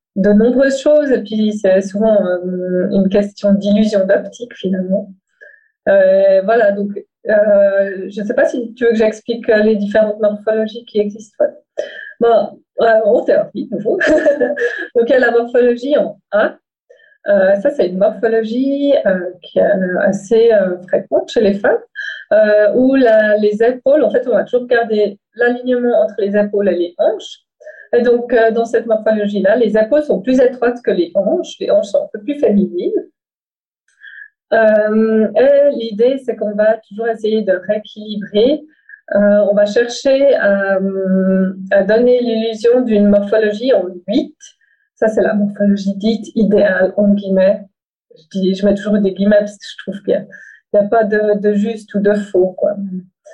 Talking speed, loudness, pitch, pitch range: 170 wpm, -14 LUFS, 220 Hz, 205-260 Hz